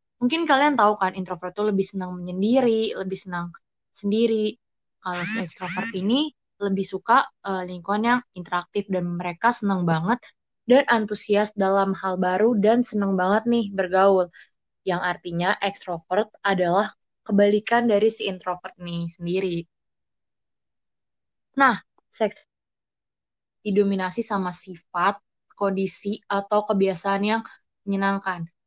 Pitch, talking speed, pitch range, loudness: 195 Hz, 115 wpm, 185-215 Hz, -24 LUFS